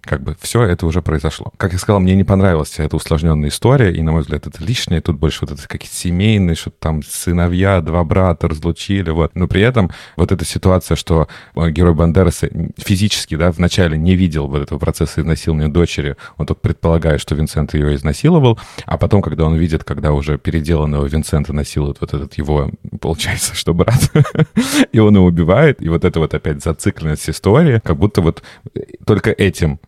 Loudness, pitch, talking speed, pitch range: -15 LUFS, 85 Hz, 185 wpm, 80-95 Hz